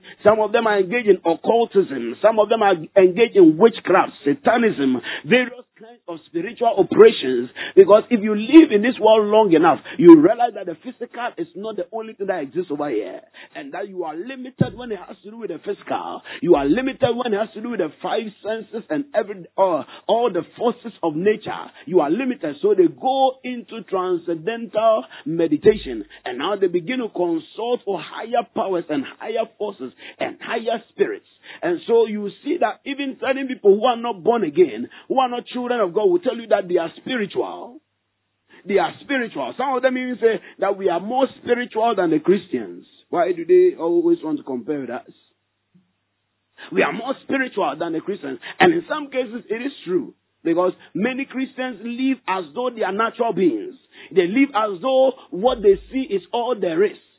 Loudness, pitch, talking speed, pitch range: -19 LUFS, 235 Hz, 195 wpm, 200-270 Hz